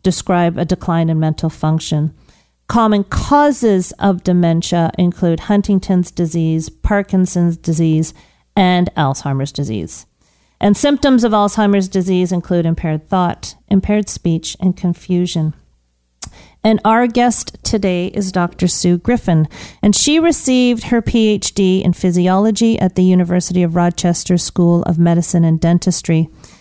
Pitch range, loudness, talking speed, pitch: 165-200 Hz, -14 LUFS, 125 wpm, 180 Hz